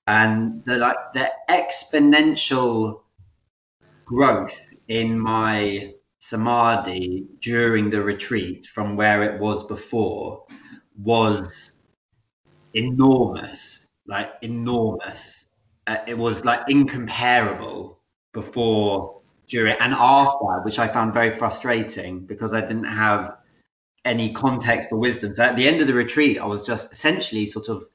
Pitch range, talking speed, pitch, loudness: 105-120 Hz, 120 wpm, 110 Hz, -21 LUFS